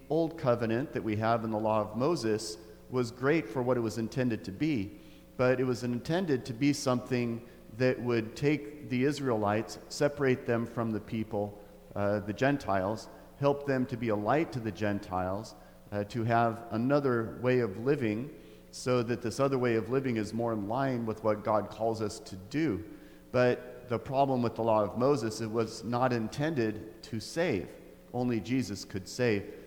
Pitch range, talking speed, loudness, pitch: 110-130 Hz, 185 wpm, -31 LUFS, 115 Hz